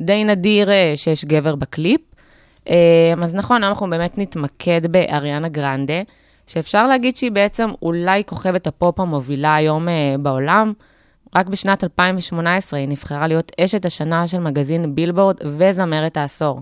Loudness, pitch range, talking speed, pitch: -17 LUFS, 155-195 Hz, 125 wpm, 170 Hz